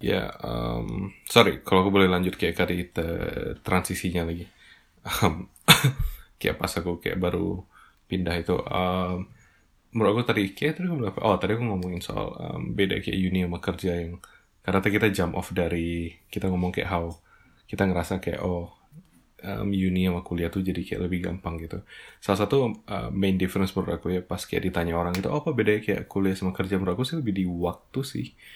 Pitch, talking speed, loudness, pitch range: 95 Hz, 190 wpm, -26 LUFS, 85-100 Hz